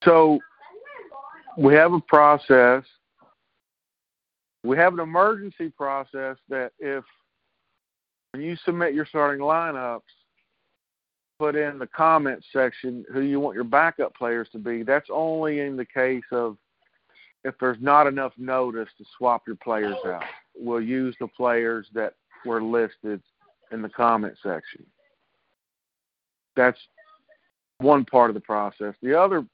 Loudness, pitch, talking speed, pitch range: -22 LUFS, 130 Hz, 135 wpm, 120-150 Hz